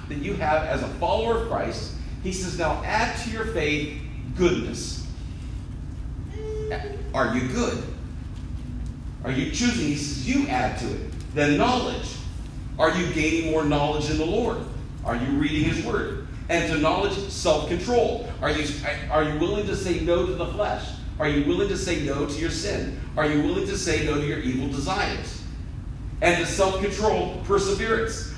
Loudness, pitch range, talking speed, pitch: -25 LUFS, 130-170 Hz, 175 wpm, 150 Hz